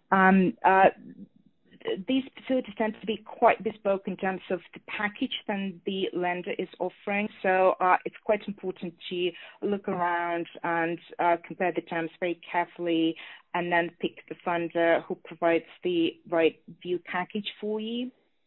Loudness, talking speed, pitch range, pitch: -28 LUFS, 155 wpm, 175-215 Hz, 185 Hz